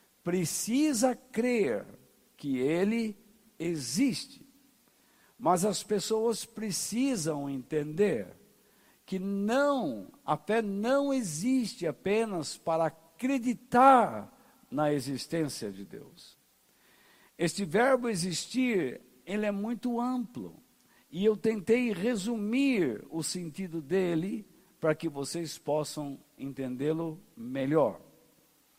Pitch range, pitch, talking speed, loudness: 165-240 Hz, 210 Hz, 90 wpm, -30 LUFS